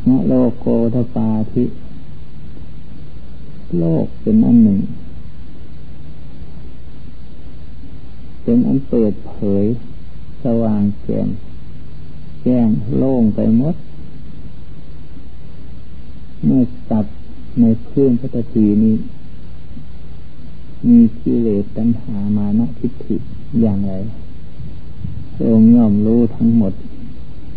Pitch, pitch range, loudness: 110 Hz, 90-120 Hz, -16 LUFS